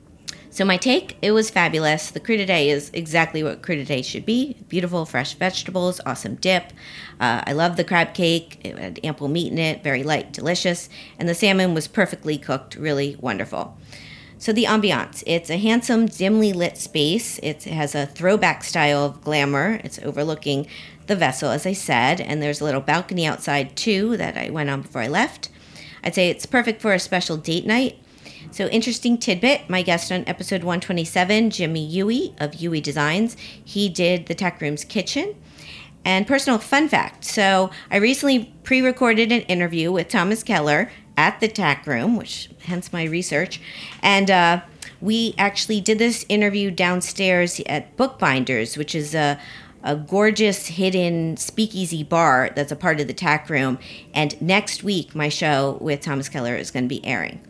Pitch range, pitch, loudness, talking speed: 150-205 Hz, 175 Hz, -21 LUFS, 175 wpm